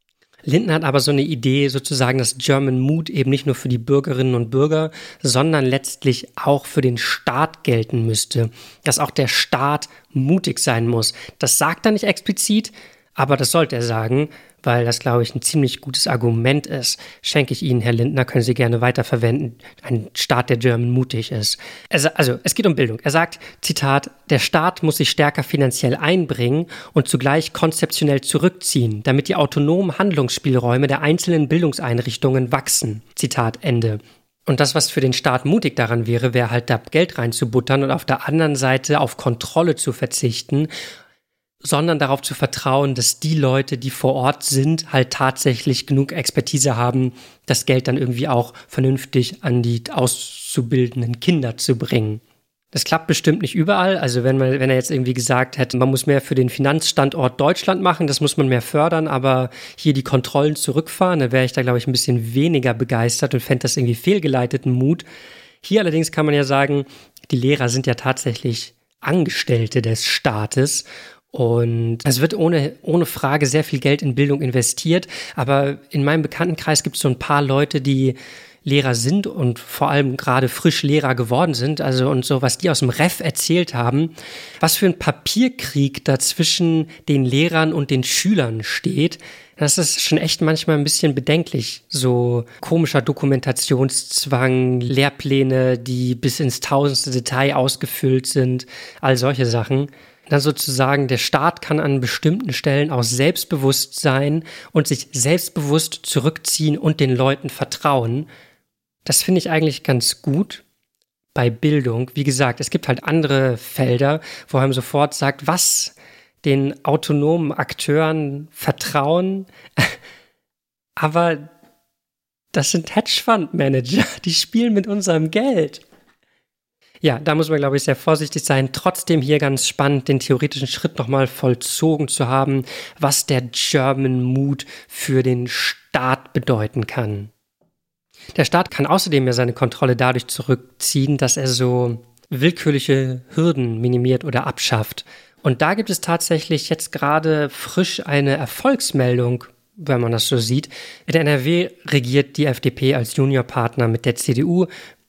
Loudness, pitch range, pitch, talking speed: -18 LUFS, 125-155 Hz, 140 Hz, 160 wpm